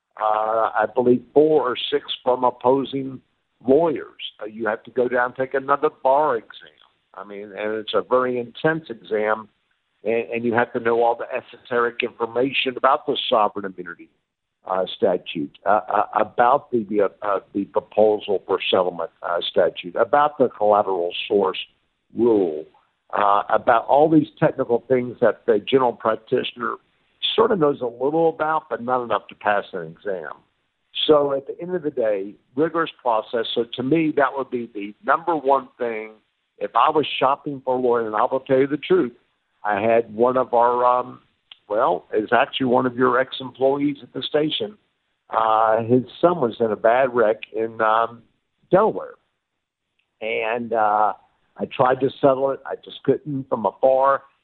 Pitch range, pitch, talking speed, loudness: 110-135 Hz, 125 Hz, 170 wpm, -21 LUFS